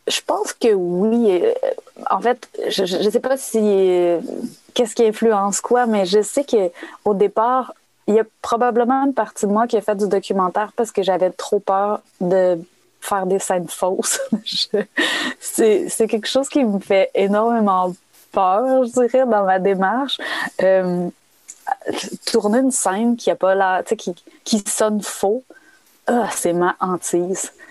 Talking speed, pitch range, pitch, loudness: 165 wpm, 190-250 Hz, 215 Hz, -19 LUFS